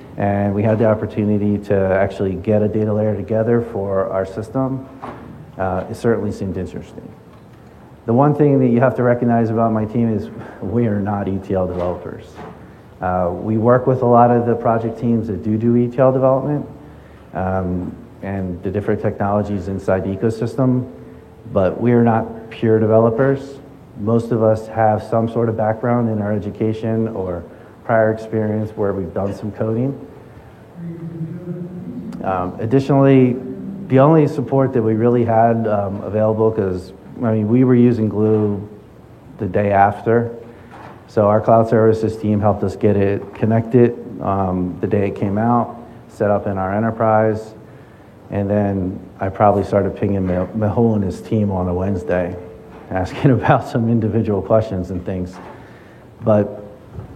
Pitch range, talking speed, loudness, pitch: 100-120 Hz, 155 wpm, -18 LUFS, 110 Hz